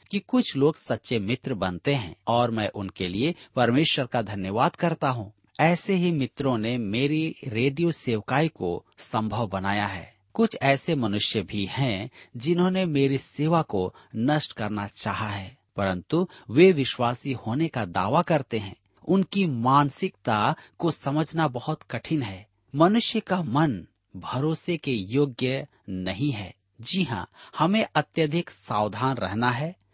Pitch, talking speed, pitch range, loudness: 130 Hz, 140 wpm, 105-160 Hz, -26 LUFS